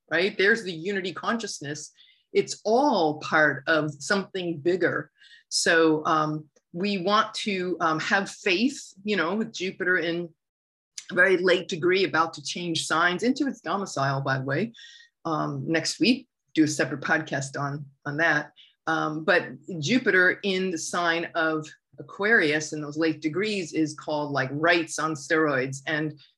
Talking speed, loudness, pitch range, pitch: 150 wpm, -25 LUFS, 155-195 Hz, 165 Hz